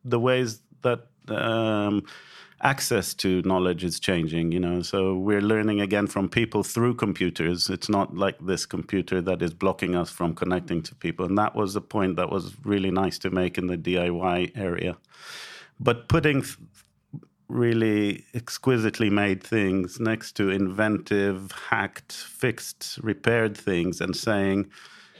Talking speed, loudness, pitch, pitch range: 150 wpm, -25 LUFS, 100 Hz, 90-110 Hz